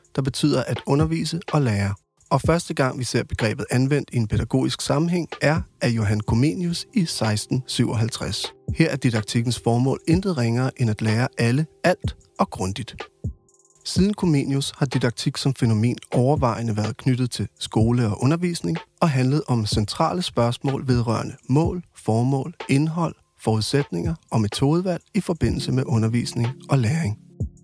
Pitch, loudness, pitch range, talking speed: 130 Hz, -23 LUFS, 115-150 Hz, 145 wpm